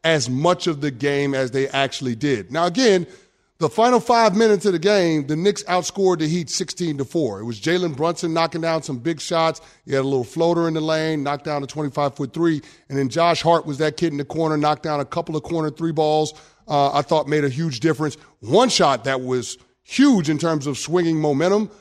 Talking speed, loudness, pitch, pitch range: 230 wpm, -20 LUFS, 160 Hz, 145-170 Hz